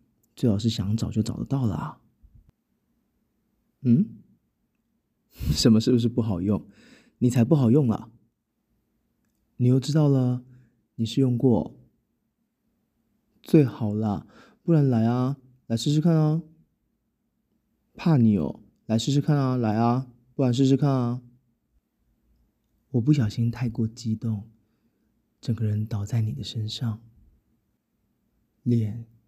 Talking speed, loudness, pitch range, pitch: 170 characters per minute, -24 LUFS, 110-130 Hz, 120 Hz